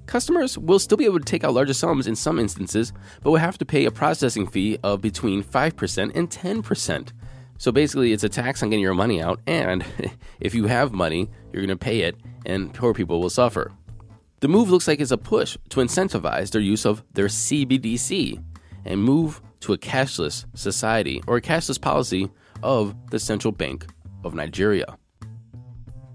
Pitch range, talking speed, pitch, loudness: 100-135 Hz, 185 wpm, 115 Hz, -22 LUFS